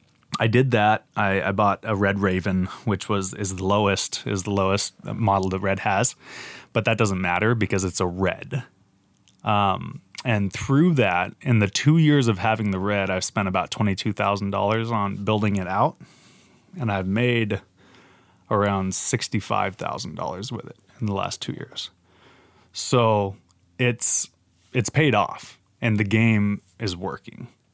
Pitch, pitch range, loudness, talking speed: 100 Hz, 95-115 Hz, -23 LUFS, 165 wpm